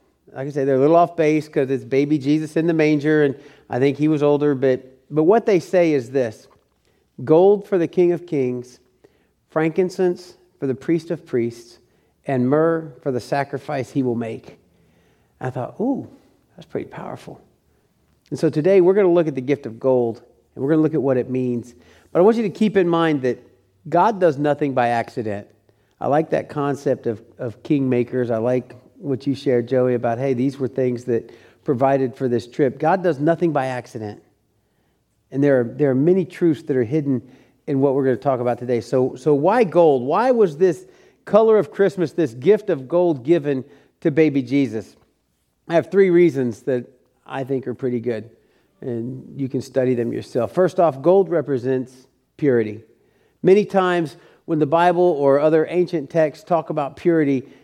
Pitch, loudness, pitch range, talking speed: 140 Hz, -19 LUFS, 125-165 Hz, 195 wpm